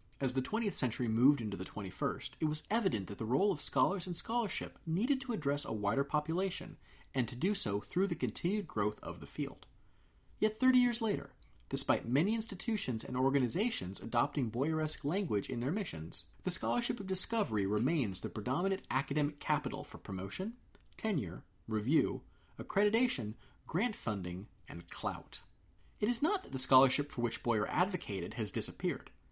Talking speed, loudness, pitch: 165 wpm, -35 LUFS, 140 Hz